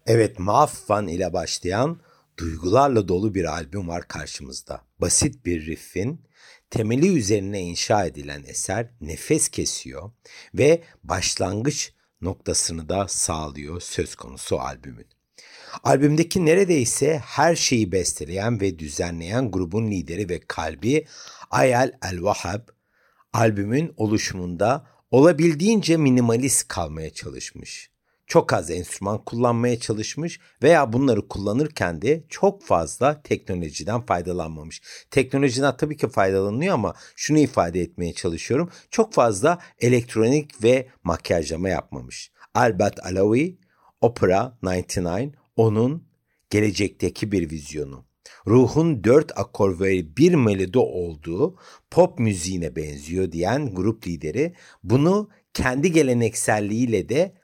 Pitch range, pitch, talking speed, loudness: 90-140 Hz, 110 Hz, 105 wpm, -22 LUFS